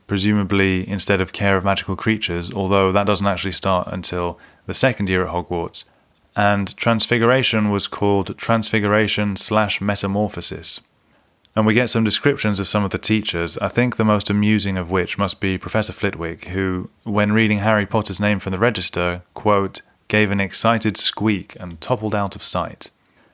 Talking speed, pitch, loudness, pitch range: 165 wpm, 100 Hz, -19 LUFS, 95-110 Hz